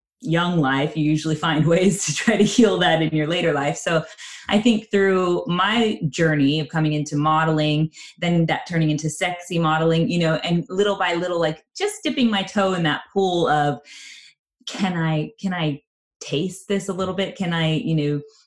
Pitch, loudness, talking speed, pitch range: 165 Hz, -21 LUFS, 190 wpm, 155-190 Hz